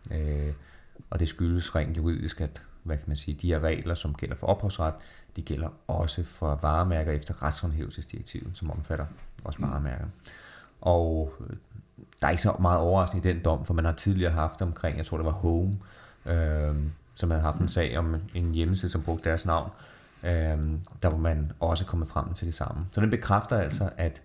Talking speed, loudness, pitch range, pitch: 195 wpm, -29 LUFS, 80-90 Hz, 85 Hz